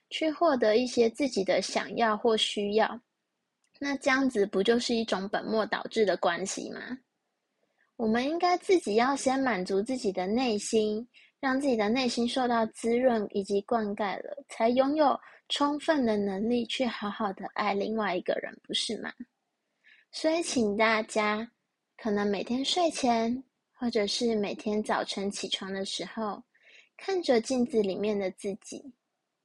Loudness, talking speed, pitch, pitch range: -29 LUFS, 230 characters per minute, 230 Hz, 210-260 Hz